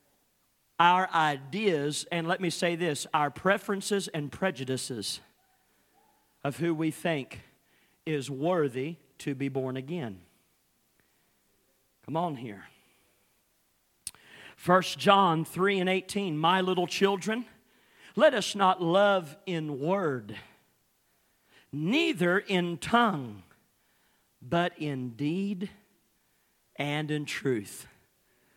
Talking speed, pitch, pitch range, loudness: 100 wpm, 170 Hz, 145-190 Hz, -29 LUFS